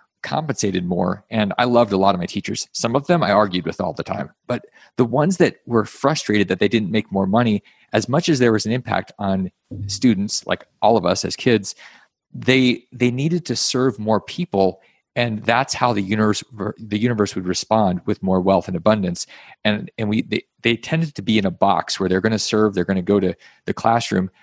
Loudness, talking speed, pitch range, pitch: -20 LUFS, 220 wpm, 95-120 Hz, 110 Hz